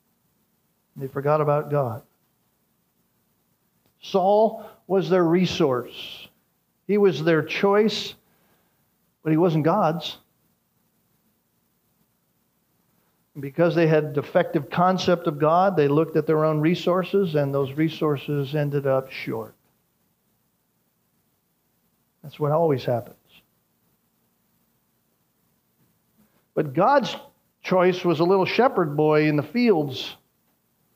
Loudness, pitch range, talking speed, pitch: -22 LUFS, 150-185 Hz, 100 wpm, 160 Hz